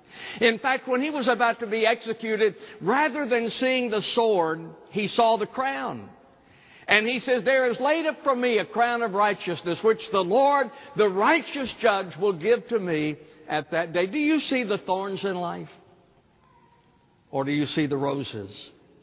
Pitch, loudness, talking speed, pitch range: 220 Hz, -24 LUFS, 180 wpm, 175-255 Hz